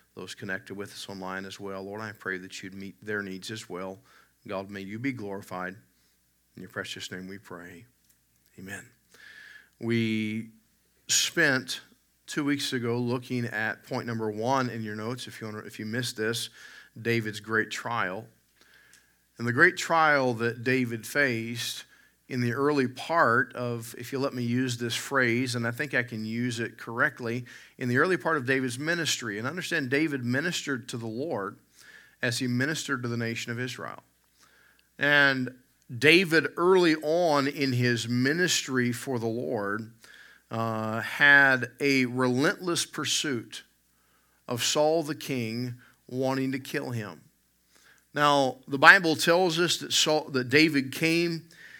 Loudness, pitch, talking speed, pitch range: -27 LUFS, 125 Hz, 155 wpm, 110-140 Hz